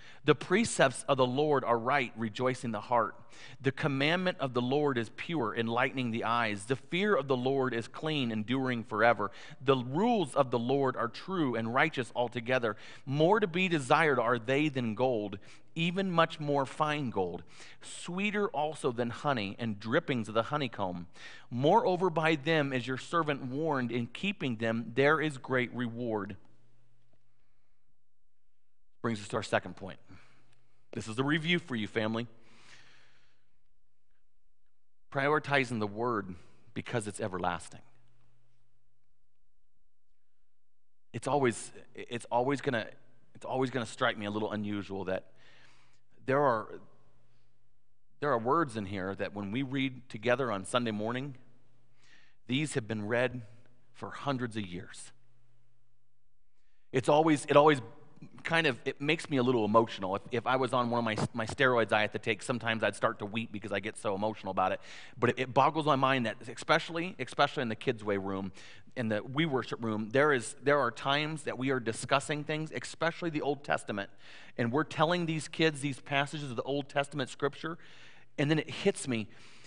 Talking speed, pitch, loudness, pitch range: 165 wpm, 125 Hz, -31 LUFS, 115-145 Hz